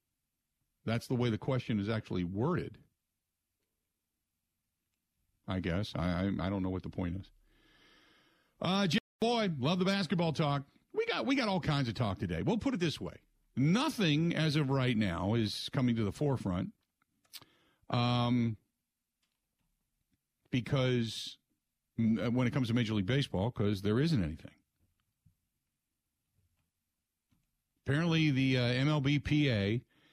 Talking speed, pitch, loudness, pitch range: 135 wpm, 115 Hz, -33 LUFS, 95-145 Hz